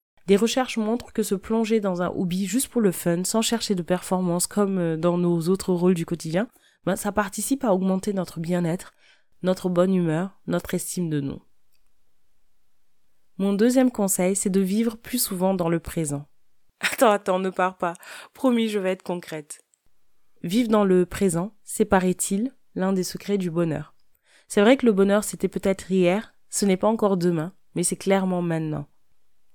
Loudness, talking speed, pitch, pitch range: -24 LUFS, 175 wpm, 185 Hz, 175-210 Hz